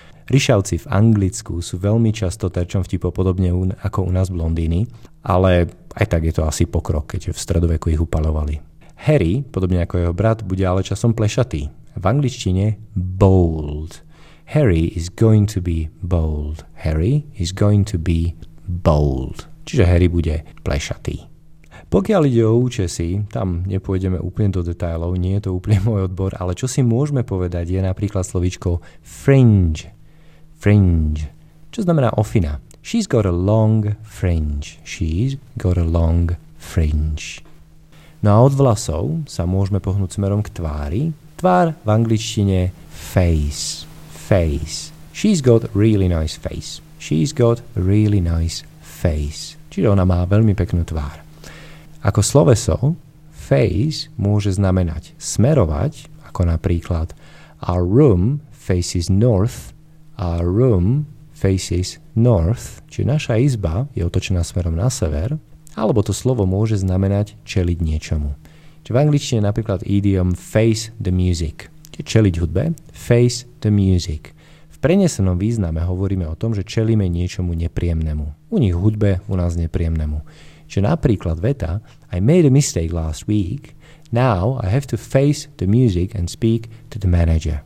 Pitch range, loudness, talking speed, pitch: 85-120 Hz, -19 LUFS, 140 wpm, 95 Hz